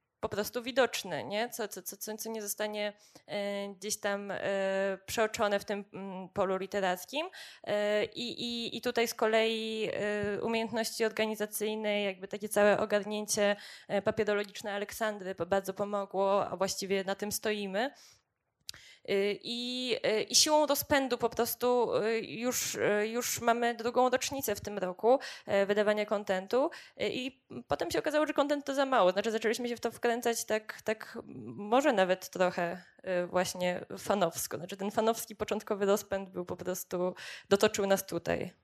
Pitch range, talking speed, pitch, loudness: 195-230 Hz, 135 wpm, 210 Hz, -32 LUFS